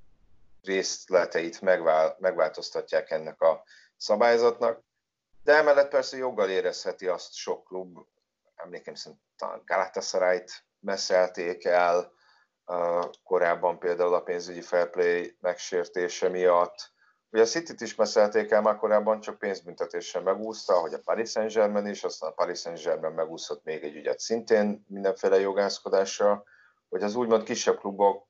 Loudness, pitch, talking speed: -27 LUFS, 115 Hz, 125 wpm